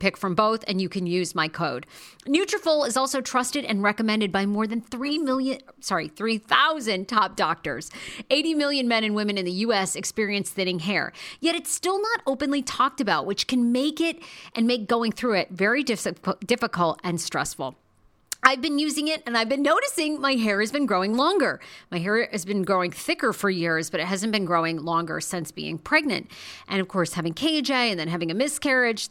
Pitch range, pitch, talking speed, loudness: 195-275 Hz, 225 Hz, 200 wpm, -24 LUFS